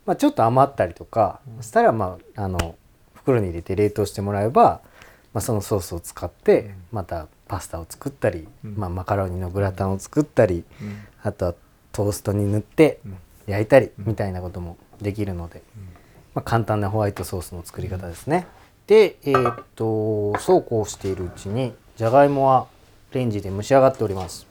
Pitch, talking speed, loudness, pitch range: 105 Hz, 365 characters per minute, -22 LUFS, 95-115 Hz